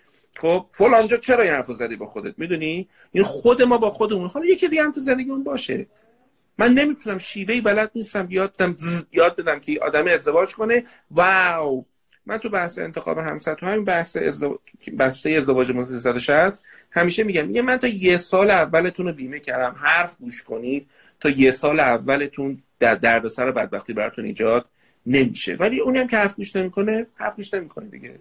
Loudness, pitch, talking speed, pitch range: -20 LUFS, 185 Hz, 170 wpm, 145-225 Hz